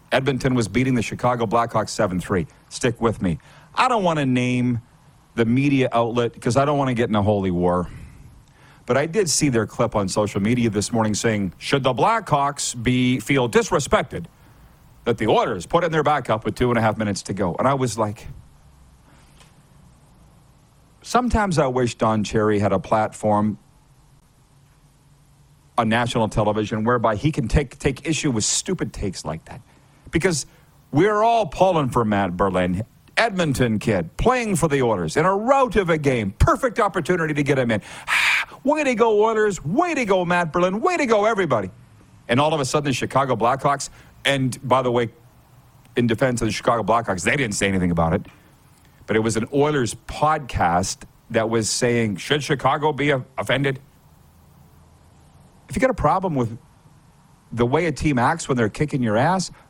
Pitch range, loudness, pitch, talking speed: 110-150 Hz, -21 LUFS, 130 Hz, 180 wpm